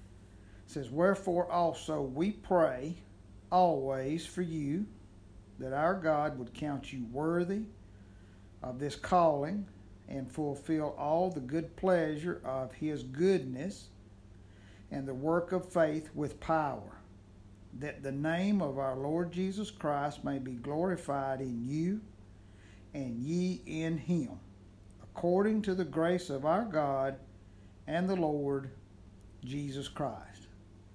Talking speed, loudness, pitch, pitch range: 125 wpm, -34 LUFS, 140 Hz, 100-165 Hz